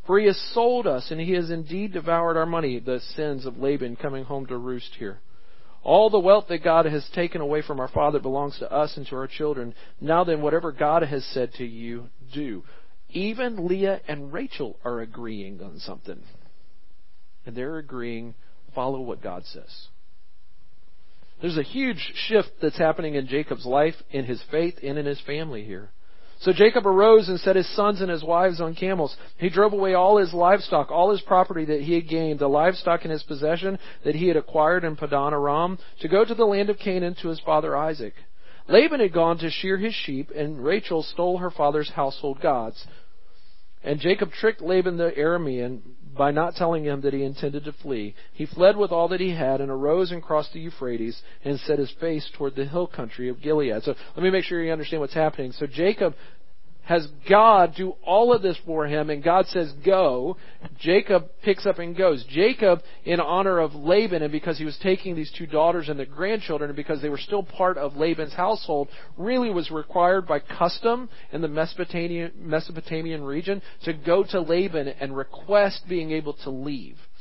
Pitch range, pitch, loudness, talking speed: 145-180 Hz, 160 Hz, -24 LUFS, 195 wpm